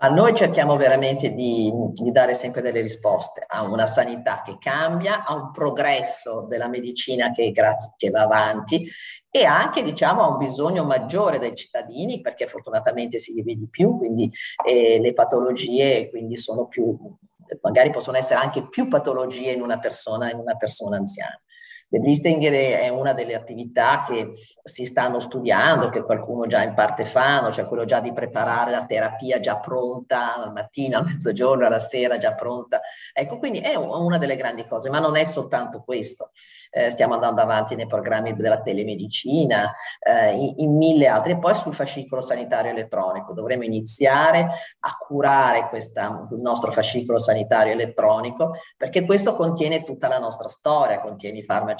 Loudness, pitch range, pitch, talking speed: -21 LUFS, 120-190 Hz, 135 Hz, 165 wpm